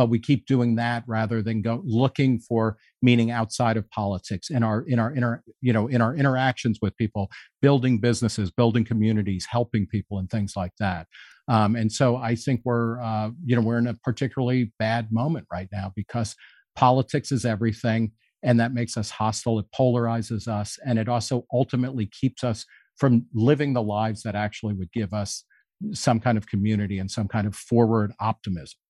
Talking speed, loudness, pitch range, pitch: 190 wpm, -24 LUFS, 110-125 Hz, 115 Hz